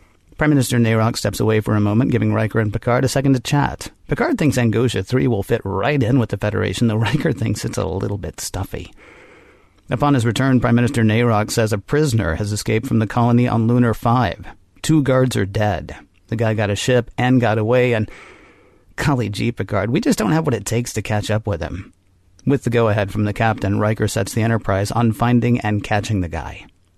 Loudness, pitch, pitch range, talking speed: -18 LUFS, 110 Hz, 105-125 Hz, 215 wpm